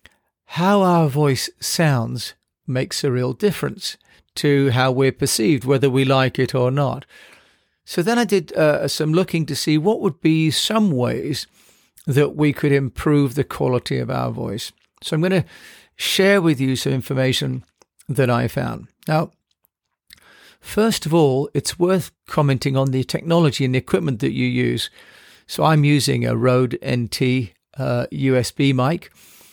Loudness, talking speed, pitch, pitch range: -19 LUFS, 160 wpm, 140 Hz, 130-160 Hz